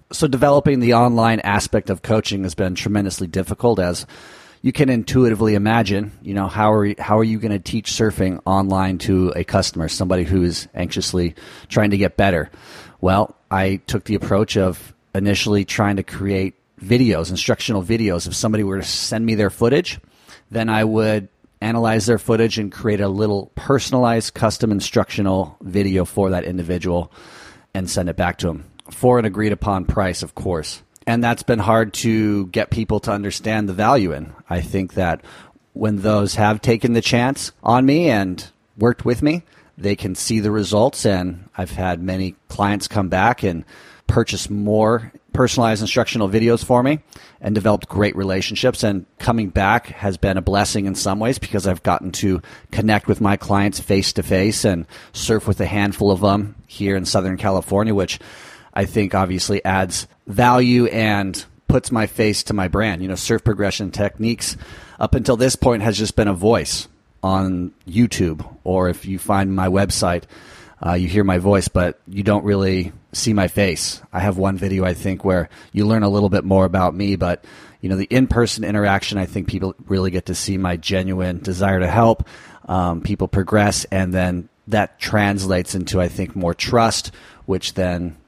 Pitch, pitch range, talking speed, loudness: 100 Hz, 95-110 Hz, 180 wpm, -19 LUFS